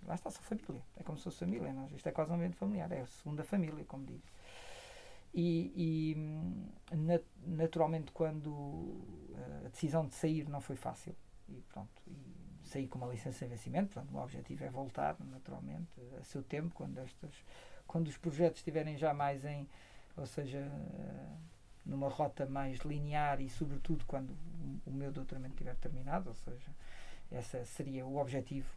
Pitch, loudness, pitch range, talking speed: 150 Hz, -41 LUFS, 135-165 Hz, 170 wpm